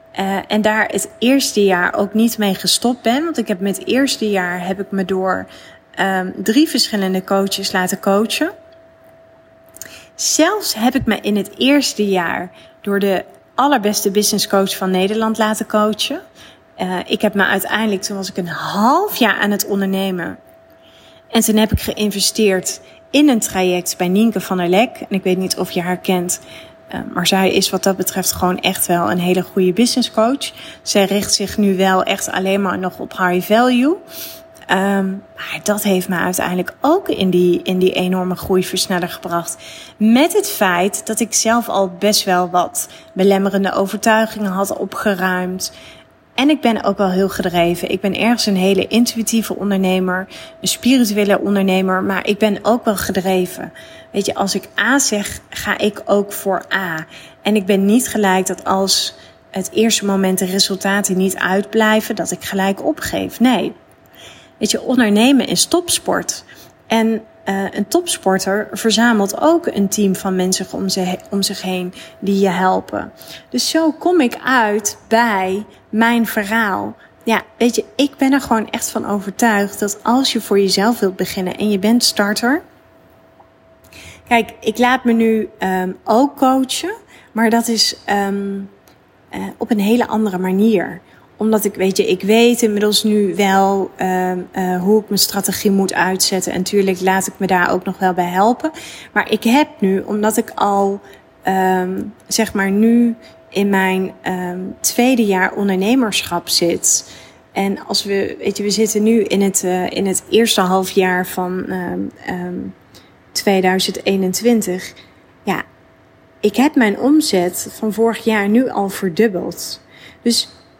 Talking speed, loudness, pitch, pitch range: 165 wpm, -16 LUFS, 200 Hz, 185-225 Hz